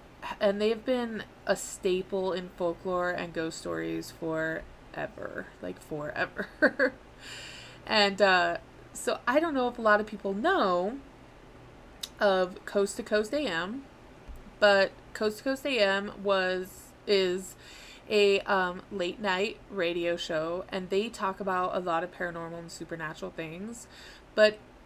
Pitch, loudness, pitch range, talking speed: 190 Hz, -29 LUFS, 175-210 Hz, 135 wpm